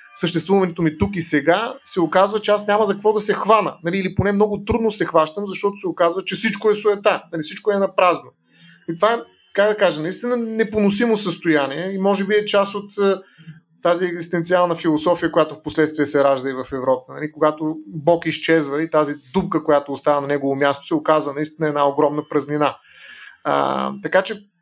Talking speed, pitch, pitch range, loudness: 195 wpm, 170 Hz, 155-200 Hz, -19 LUFS